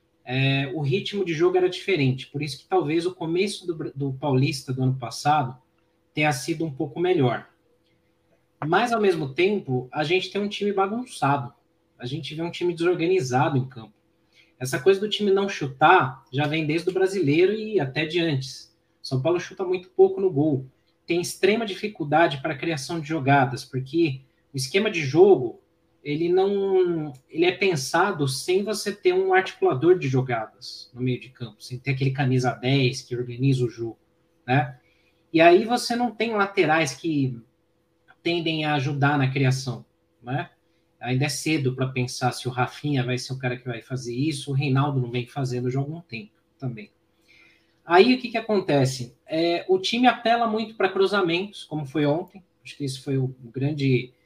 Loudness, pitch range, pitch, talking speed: -24 LUFS, 130-185 Hz, 155 Hz, 180 wpm